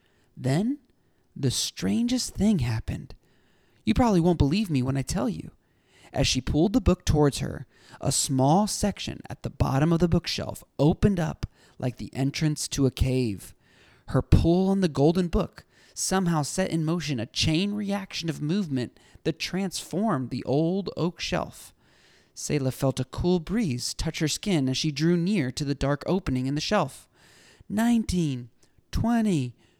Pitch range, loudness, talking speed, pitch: 130-185 Hz, -26 LUFS, 160 wpm, 155 Hz